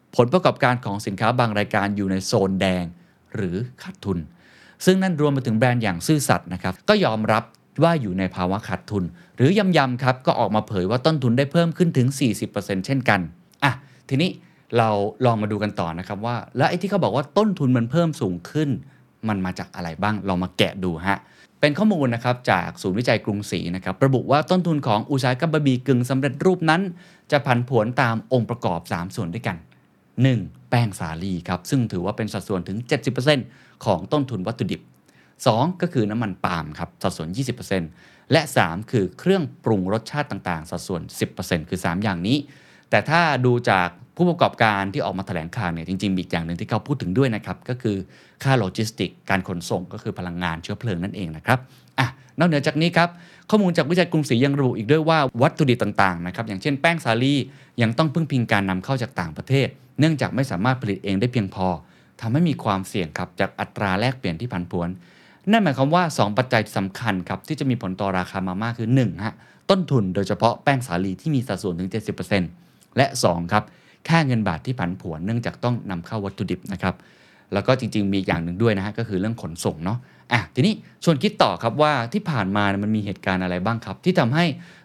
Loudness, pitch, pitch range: -22 LUFS, 115 Hz, 95-140 Hz